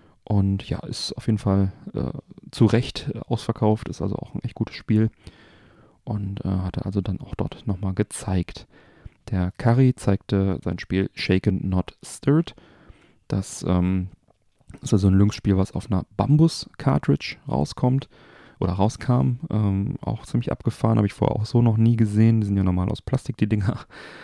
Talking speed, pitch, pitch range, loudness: 165 wpm, 105 Hz, 95-115 Hz, -23 LUFS